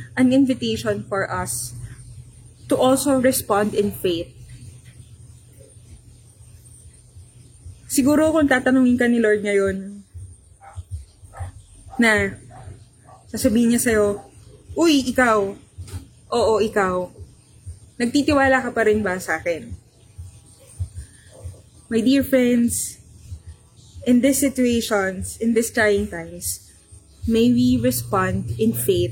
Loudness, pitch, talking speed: -20 LUFS, 125 Hz, 95 wpm